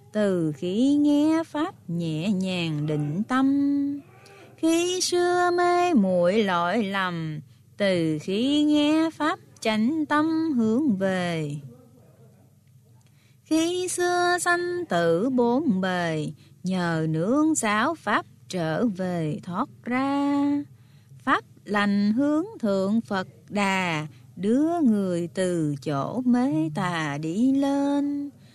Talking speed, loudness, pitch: 105 wpm, -24 LUFS, 205 Hz